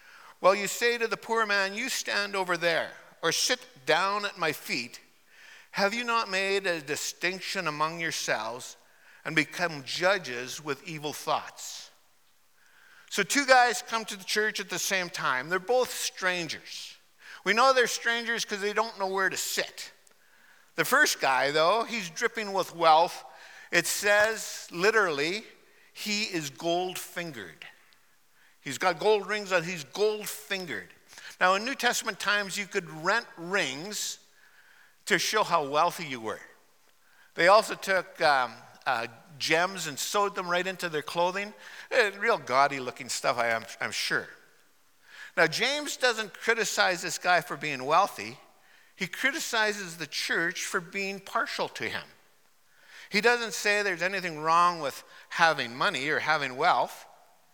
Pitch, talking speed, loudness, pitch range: 195 Hz, 150 wpm, -27 LUFS, 175-220 Hz